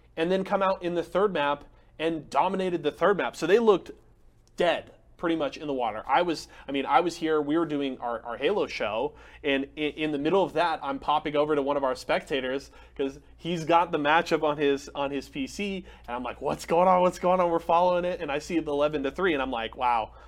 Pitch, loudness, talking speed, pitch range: 155 Hz, -27 LUFS, 250 wpm, 140-175 Hz